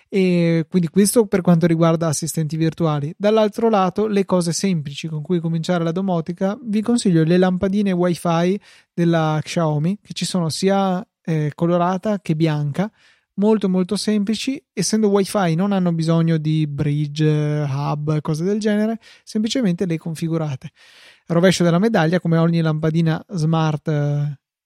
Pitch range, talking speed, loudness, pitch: 160-195 Hz, 145 wpm, -19 LUFS, 175 Hz